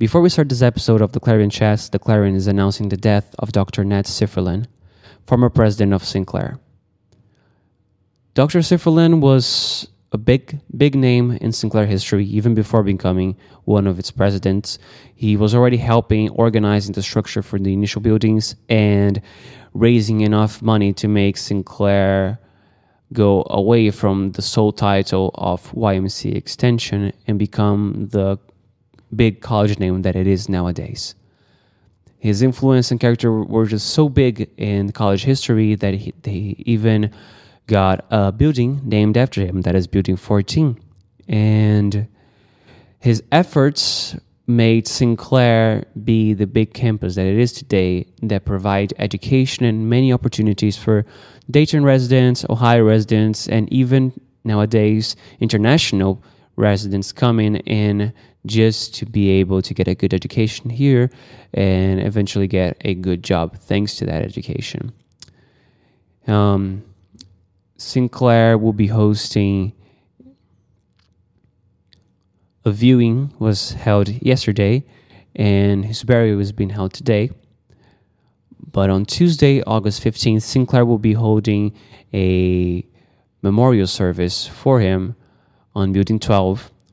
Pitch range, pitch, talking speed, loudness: 100-120 Hz, 105 Hz, 130 wpm, -17 LUFS